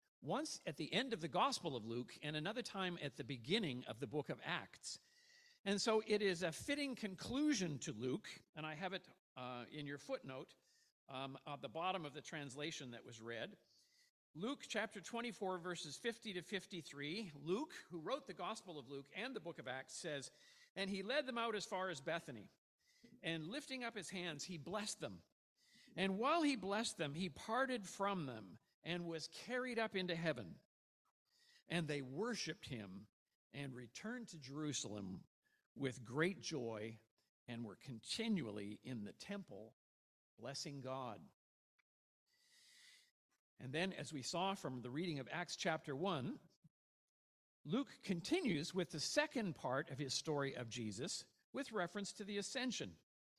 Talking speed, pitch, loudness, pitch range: 165 wpm, 170 Hz, -45 LUFS, 140-220 Hz